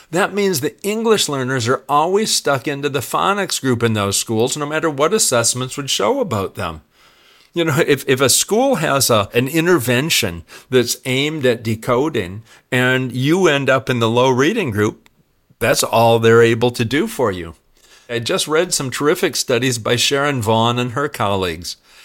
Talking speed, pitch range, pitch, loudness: 180 wpm, 120-155 Hz, 130 Hz, -16 LUFS